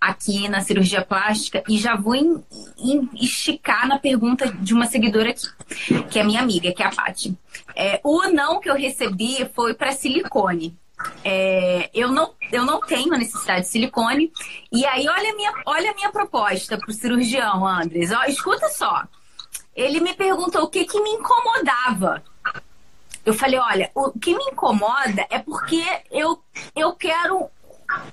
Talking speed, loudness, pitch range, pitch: 165 wpm, -20 LUFS, 215-320 Hz, 255 Hz